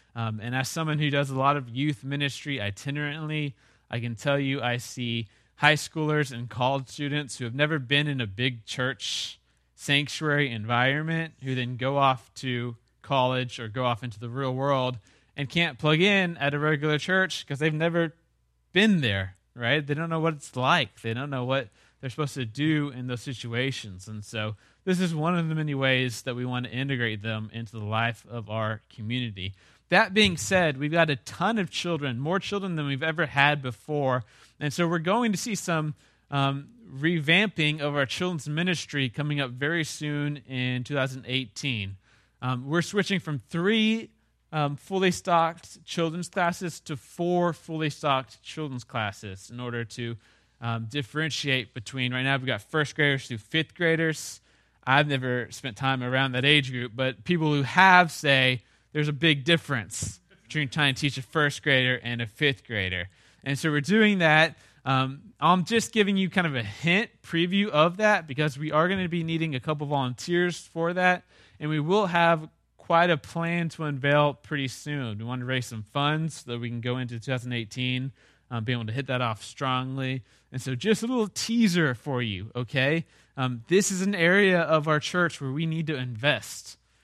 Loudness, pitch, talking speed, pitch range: -26 LUFS, 140 Hz, 190 wpm, 125-160 Hz